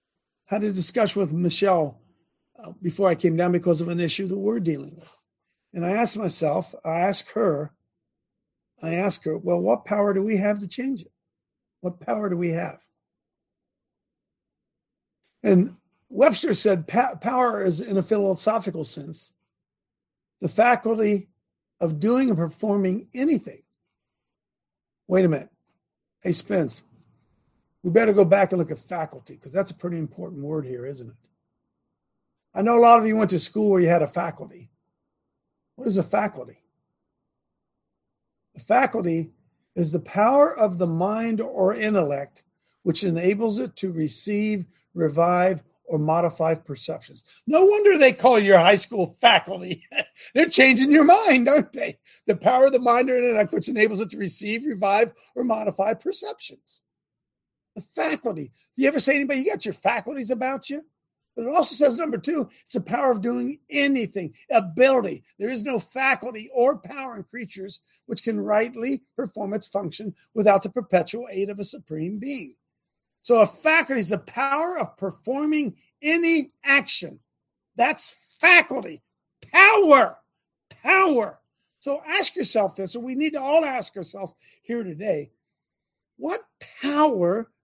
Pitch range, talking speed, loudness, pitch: 175-255 Hz, 150 wpm, -22 LUFS, 210 Hz